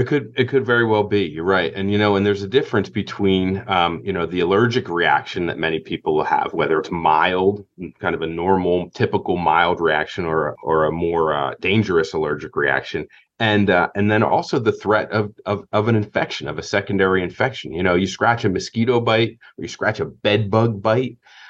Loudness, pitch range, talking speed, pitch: -19 LUFS, 95-110 Hz, 210 wpm, 100 Hz